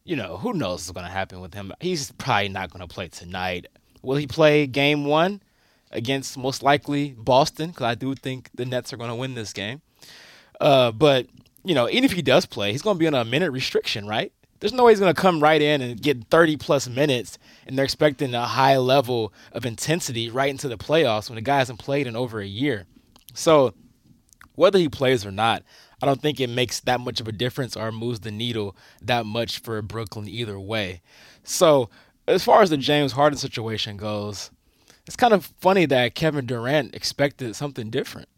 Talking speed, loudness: 210 wpm, -22 LUFS